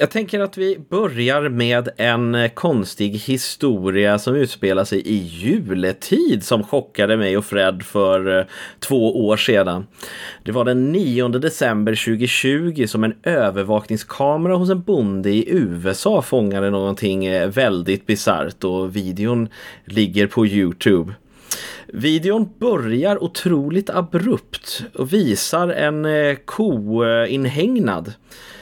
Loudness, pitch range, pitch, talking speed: -19 LUFS, 100-150 Hz, 115 Hz, 115 wpm